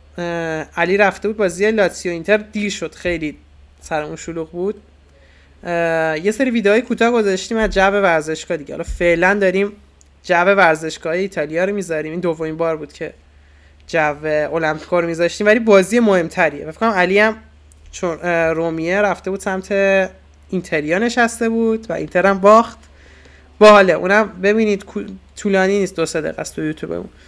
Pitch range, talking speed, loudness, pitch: 160-205 Hz, 145 wpm, -17 LUFS, 175 Hz